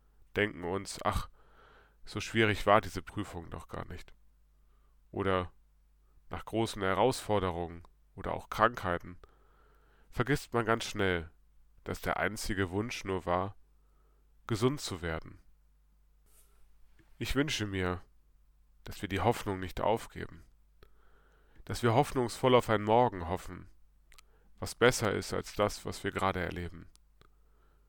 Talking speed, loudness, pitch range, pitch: 120 wpm, -33 LUFS, 80-110 Hz, 95 Hz